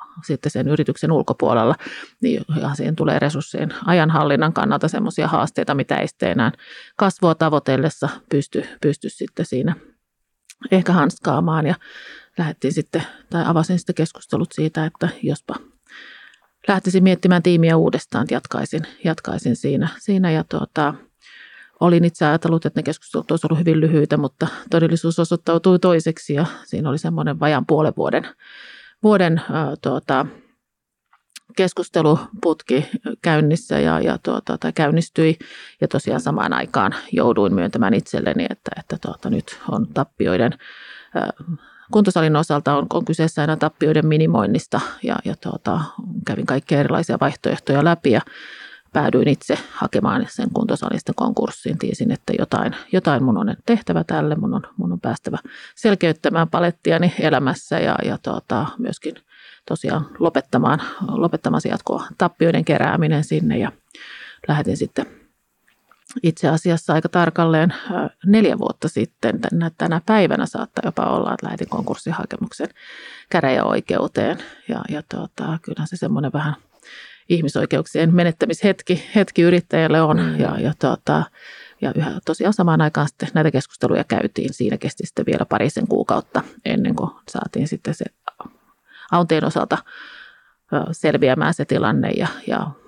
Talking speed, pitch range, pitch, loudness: 125 wpm, 155-180 Hz, 165 Hz, -20 LUFS